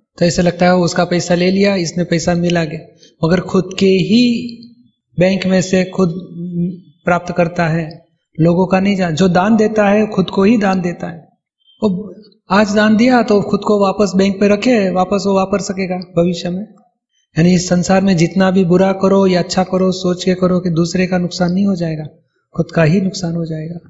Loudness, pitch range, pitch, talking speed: -14 LUFS, 175-195 Hz, 185 Hz, 205 wpm